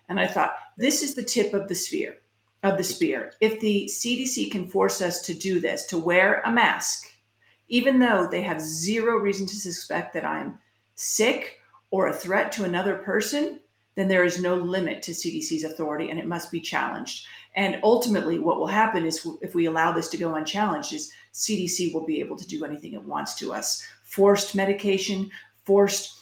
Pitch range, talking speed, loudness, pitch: 175-215 Hz, 190 wpm, -25 LUFS, 195 Hz